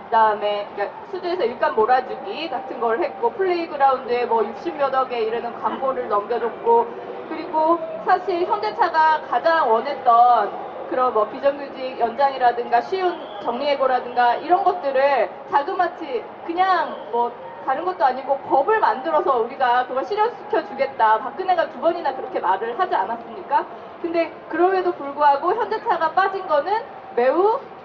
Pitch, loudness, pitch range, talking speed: 295 Hz, -21 LUFS, 250-370 Hz, 340 characters per minute